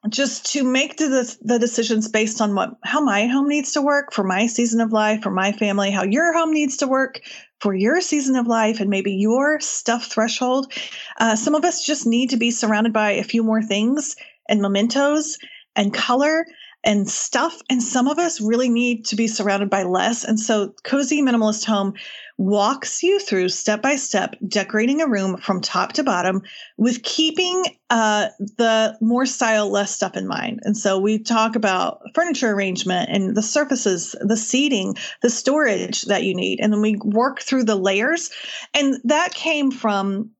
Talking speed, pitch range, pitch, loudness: 185 wpm, 210-275 Hz, 230 Hz, -20 LUFS